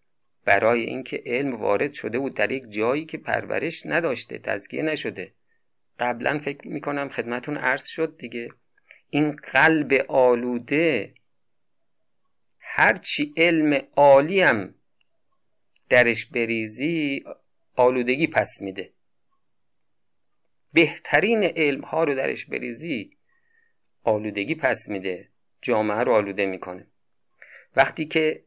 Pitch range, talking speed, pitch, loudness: 120-155 Hz, 100 wpm, 135 Hz, -23 LUFS